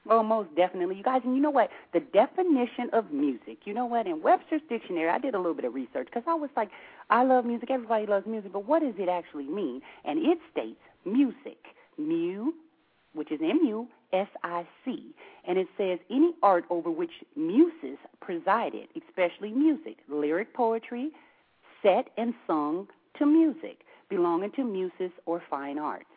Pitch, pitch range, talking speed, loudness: 240 Hz, 185-305 Hz, 180 wpm, -28 LUFS